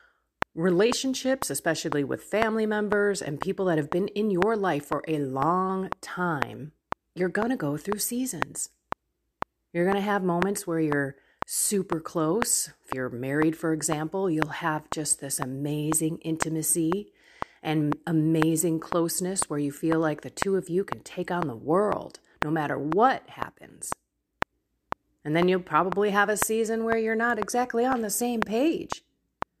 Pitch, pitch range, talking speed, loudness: 175 Hz, 155-210 Hz, 160 wpm, -27 LUFS